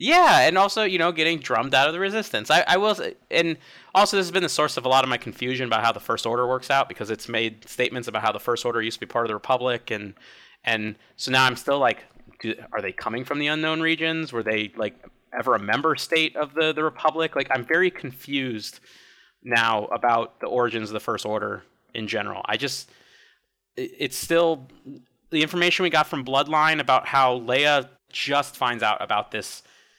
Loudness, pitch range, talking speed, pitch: -23 LUFS, 115-160 Hz, 215 wpm, 135 Hz